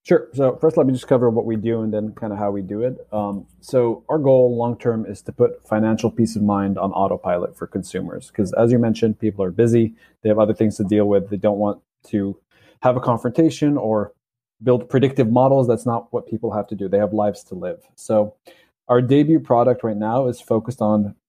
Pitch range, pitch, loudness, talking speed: 105-125 Hz, 115 Hz, -20 LUFS, 230 wpm